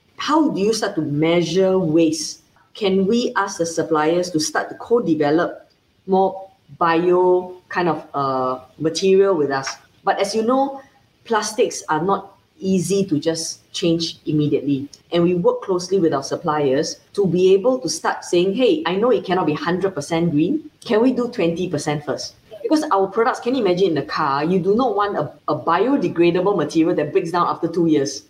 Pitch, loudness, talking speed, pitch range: 180 Hz, -19 LUFS, 180 wpm, 155-195 Hz